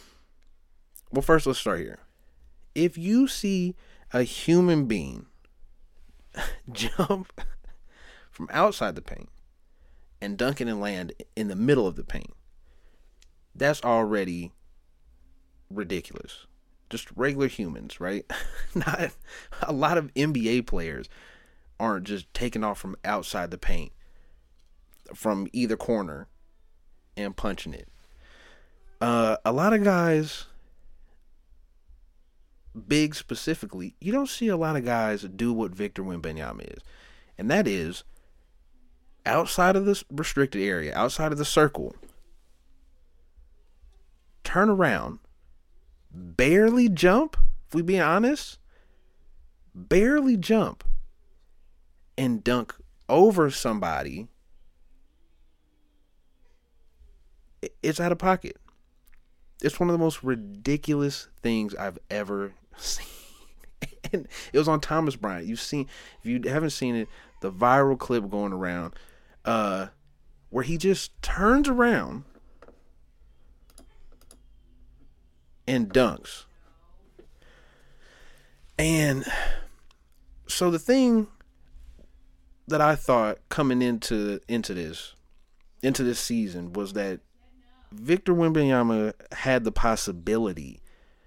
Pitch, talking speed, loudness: 100 Hz, 105 wpm, -26 LUFS